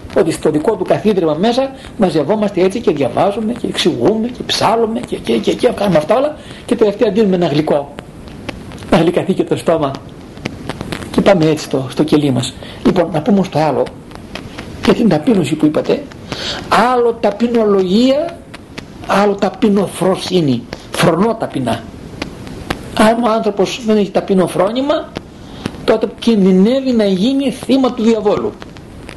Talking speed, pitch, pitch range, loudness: 140 wpm, 210 Hz, 180-230 Hz, -14 LUFS